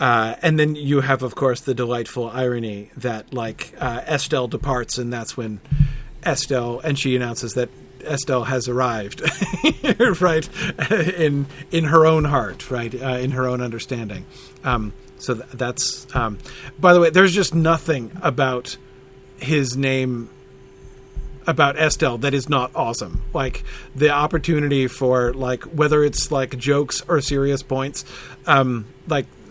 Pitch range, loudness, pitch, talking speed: 125-150 Hz, -20 LUFS, 130 Hz, 145 wpm